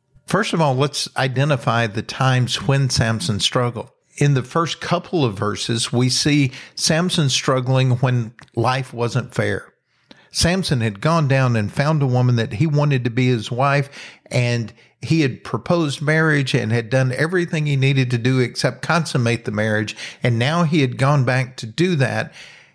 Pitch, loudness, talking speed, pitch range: 130 Hz, -19 LUFS, 170 wpm, 120-150 Hz